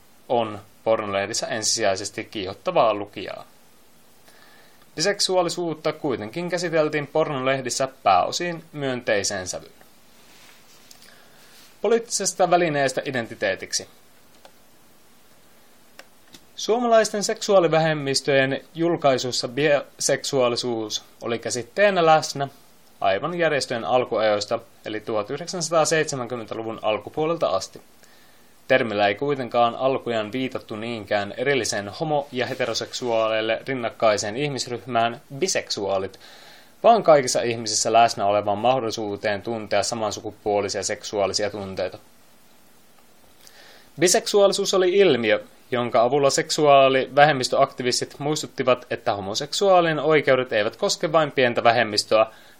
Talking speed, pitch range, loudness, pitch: 75 wpm, 110-155 Hz, -22 LUFS, 130 Hz